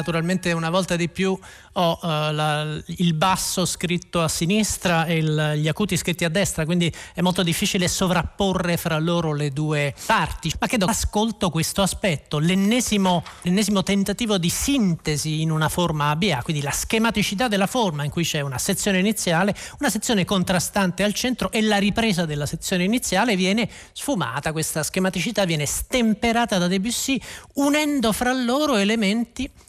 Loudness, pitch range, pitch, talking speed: -22 LUFS, 165-210 Hz, 185 Hz, 160 wpm